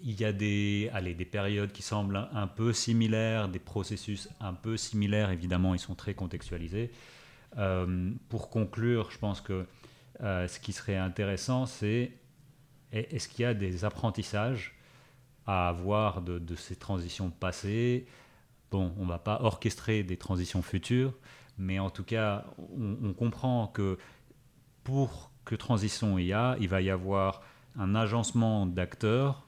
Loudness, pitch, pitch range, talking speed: -32 LUFS, 105 Hz, 95-120 Hz, 155 wpm